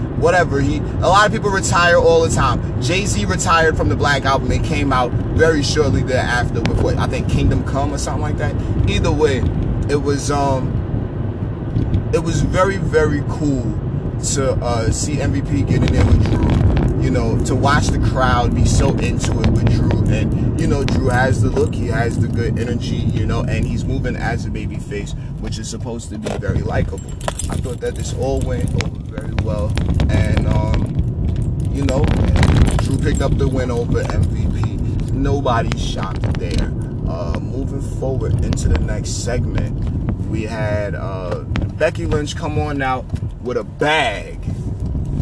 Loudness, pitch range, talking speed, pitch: -18 LUFS, 105-125 Hz, 175 wpm, 115 Hz